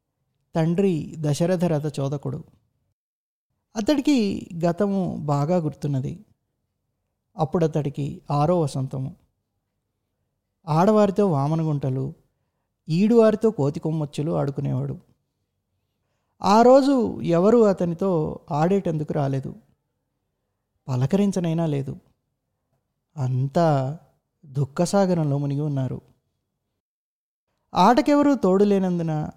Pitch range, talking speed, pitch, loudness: 135-185 Hz, 65 wpm, 155 Hz, -22 LUFS